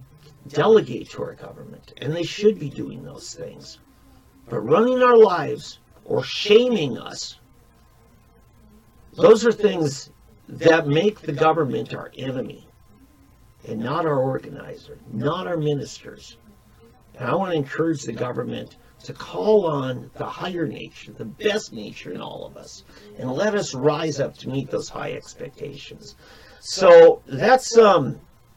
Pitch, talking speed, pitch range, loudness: 150 Hz, 140 wpm, 125-210 Hz, -20 LUFS